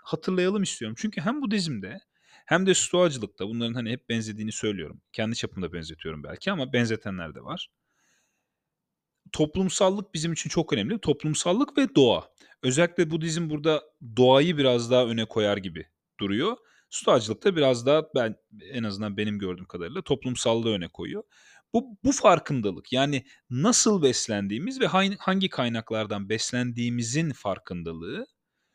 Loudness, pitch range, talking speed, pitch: -26 LUFS, 110-175 Hz, 135 wpm, 130 Hz